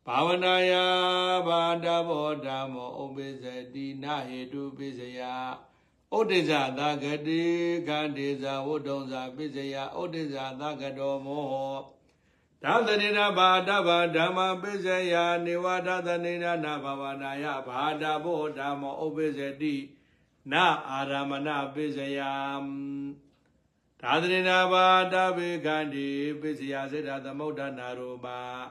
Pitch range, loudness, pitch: 135-170 Hz, -28 LUFS, 150 Hz